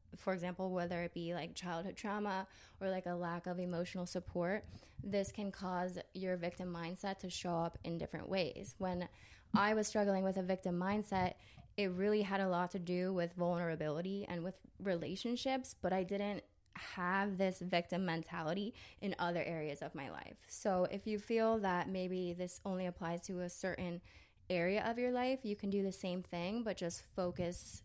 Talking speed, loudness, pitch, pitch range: 185 wpm, -40 LUFS, 185 Hz, 175-195 Hz